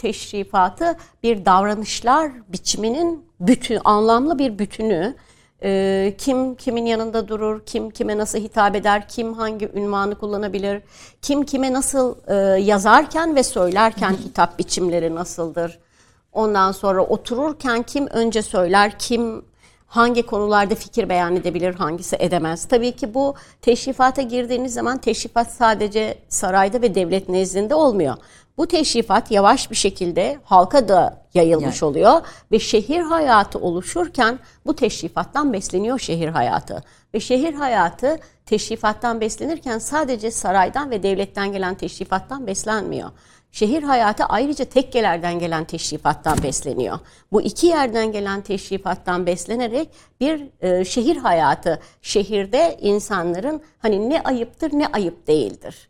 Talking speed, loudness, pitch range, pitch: 120 wpm, -19 LUFS, 190-255 Hz, 220 Hz